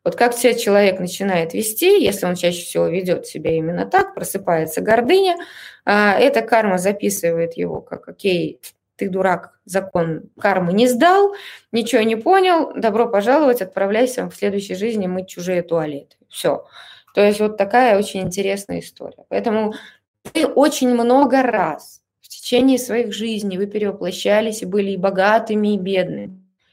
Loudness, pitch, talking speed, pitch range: -18 LUFS, 205 Hz, 145 wpm, 185-235 Hz